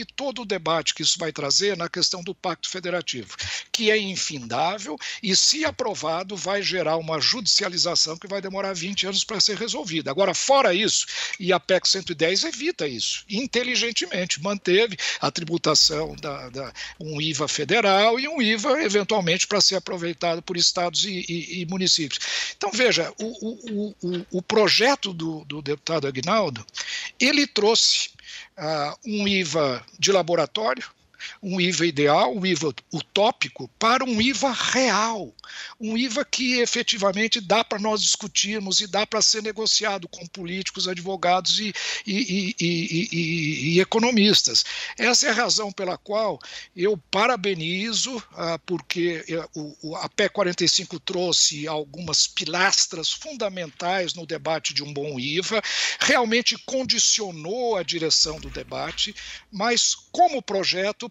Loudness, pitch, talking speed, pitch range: -22 LUFS, 190 Hz, 140 wpm, 170-220 Hz